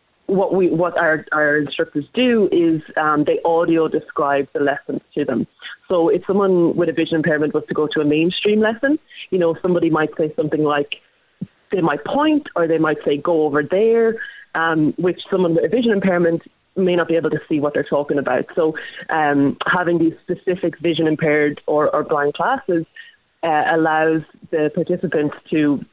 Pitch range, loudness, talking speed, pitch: 155-180 Hz, -18 LUFS, 185 wpm, 165 Hz